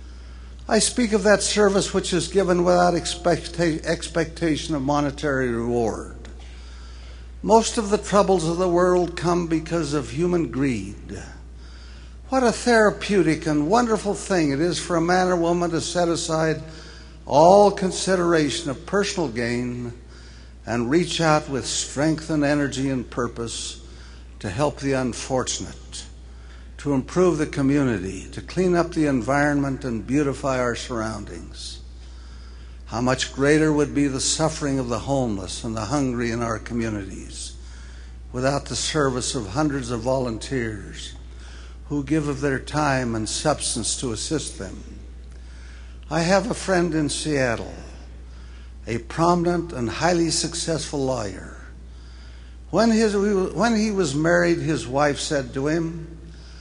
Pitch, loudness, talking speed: 140 Hz, -22 LUFS, 135 wpm